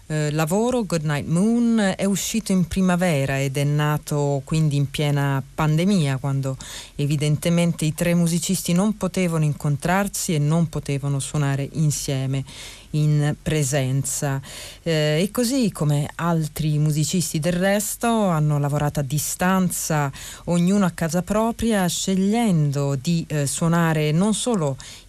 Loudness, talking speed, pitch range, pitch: -22 LUFS, 120 wpm, 145-185 Hz, 155 Hz